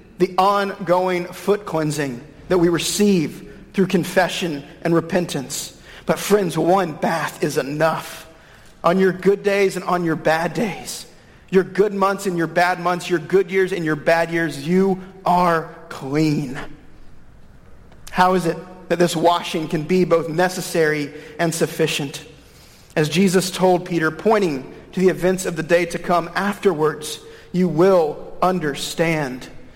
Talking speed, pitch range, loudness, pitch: 145 wpm, 160-185 Hz, -20 LUFS, 175 Hz